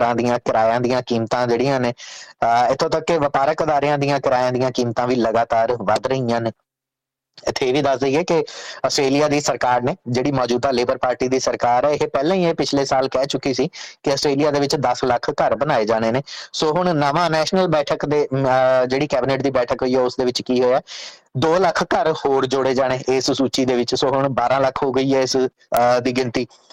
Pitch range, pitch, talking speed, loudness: 125-140 Hz, 130 Hz, 205 wpm, -19 LUFS